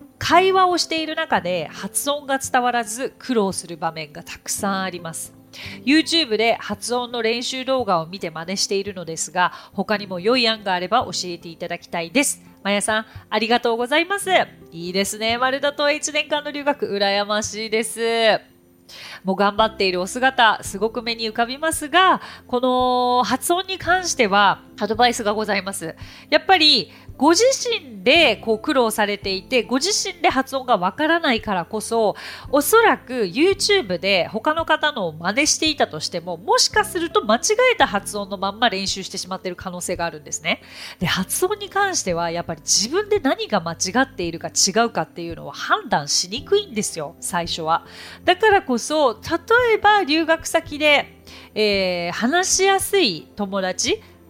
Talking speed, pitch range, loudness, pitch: 350 characters per minute, 190-310 Hz, -20 LUFS, 230 Hz